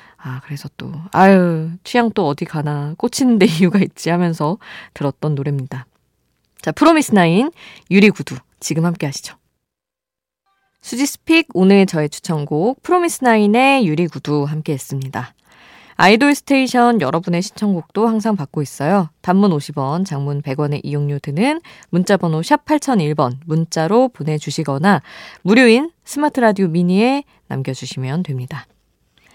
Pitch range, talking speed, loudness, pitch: 150-230 Hz, 305 characters per minute, -16 LUFS, 175 Hz